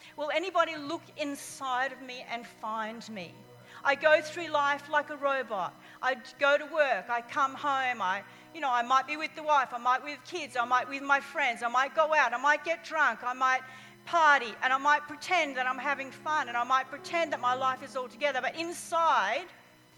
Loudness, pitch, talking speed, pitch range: -29 LUFS, 280 Hz, 220 wpm, 255-305 Hz